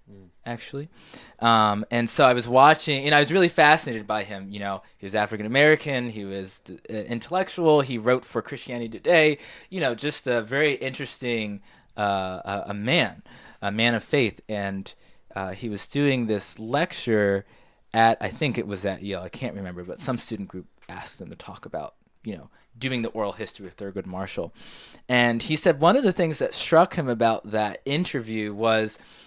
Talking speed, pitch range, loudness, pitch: 185 wpm, 100-140 Hz, -23 LUFS, 115 Hz